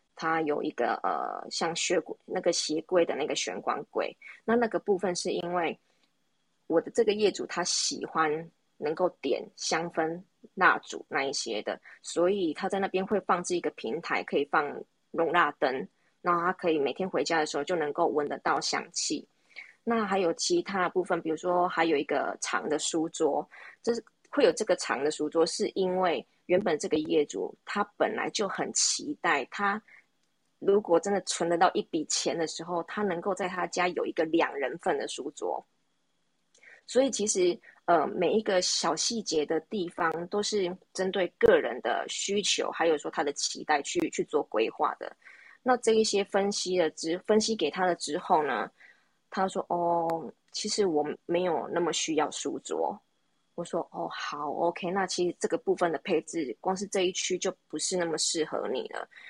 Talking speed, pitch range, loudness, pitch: 260 characters per minute, 170-215 Hz, -29 LUFS, 185 Hz